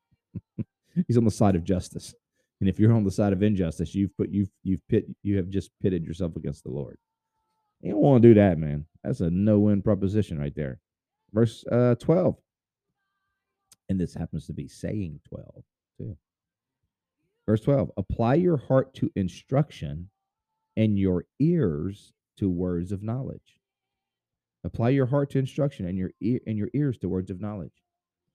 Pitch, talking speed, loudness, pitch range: 100 Hz, 170 wpm, -25 LUFS, 90-130 Hz